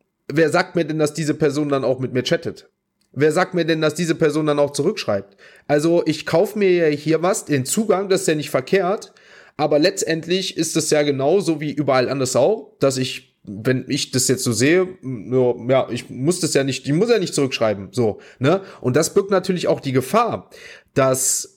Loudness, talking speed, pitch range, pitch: -19 LUFS, 210 wpm, 130-170 Hz, 150 Hz